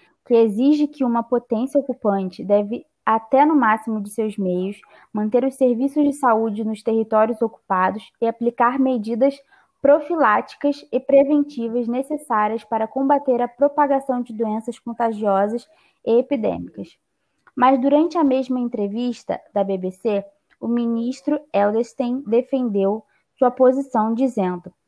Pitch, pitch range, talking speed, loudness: 240 Hz, 220-270 Hz, 125 wpm, -20 LUFS